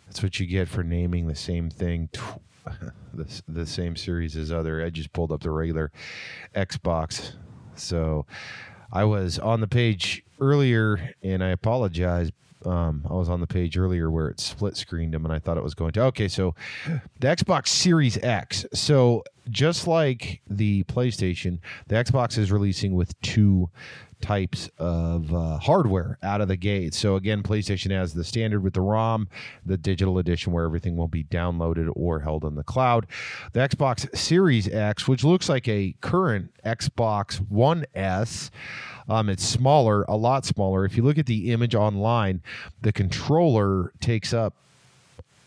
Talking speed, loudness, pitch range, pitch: 170 wpm, -25 LUFS, 85-115 Hz, 100 Hz